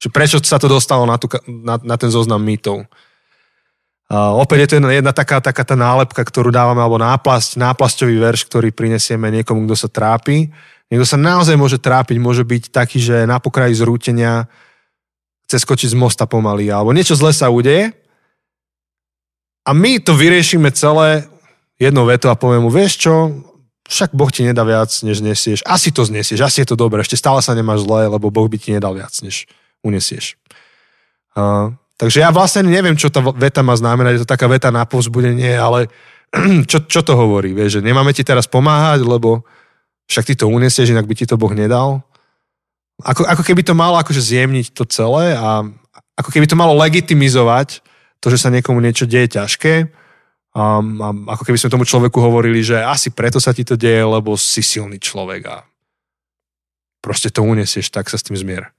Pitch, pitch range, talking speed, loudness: 125 Hz, 110-140 Hz, 185 wpm, -13 LUFS